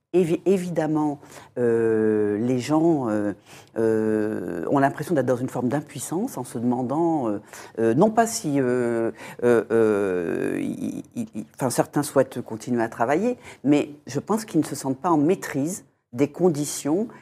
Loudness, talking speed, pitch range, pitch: -24 LUFS, 150 wpm, 115-165 Hz, 135 Hz